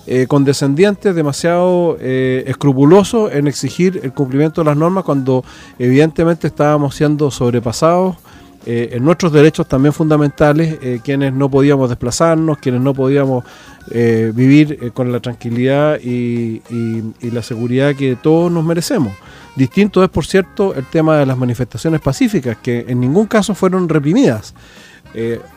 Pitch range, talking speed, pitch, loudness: 125-165 Hz, 150 wpm, 140 Hz, -14 LUFS